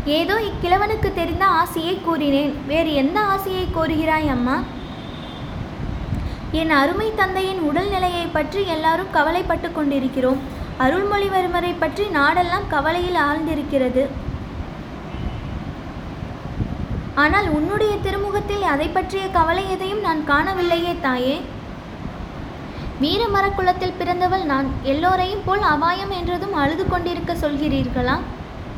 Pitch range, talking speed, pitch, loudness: 300-380 Hz, 90 wpm, 340 Hz, -20 LUFS